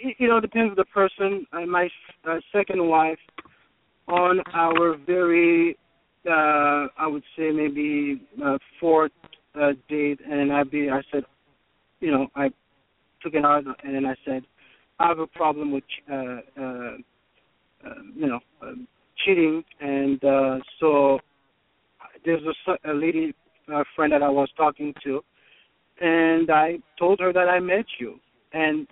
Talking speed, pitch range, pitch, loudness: 155 wpm, 140-175 Hz, 155 Hz, -23 LUFS